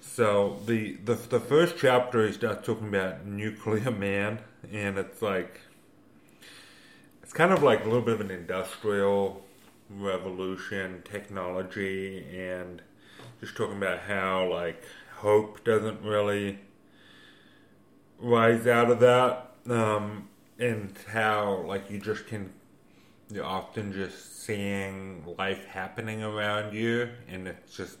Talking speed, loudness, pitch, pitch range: 125 wpm, -28 LUFS, 100 Hz, 95-110 Hz